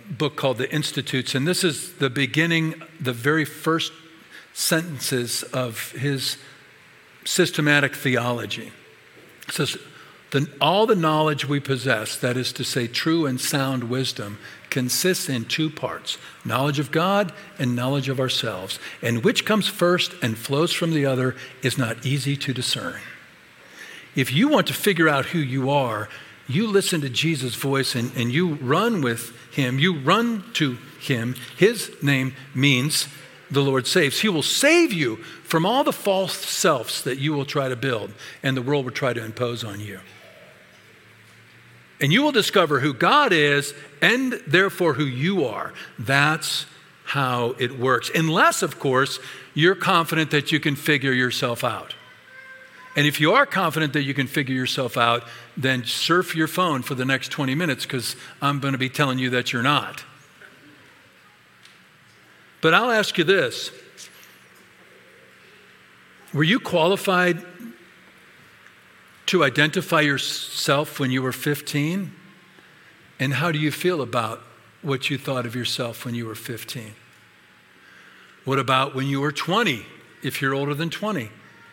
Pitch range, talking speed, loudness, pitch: 130-165 Hz, 155 wpm, -22 LUFS, 140 Hz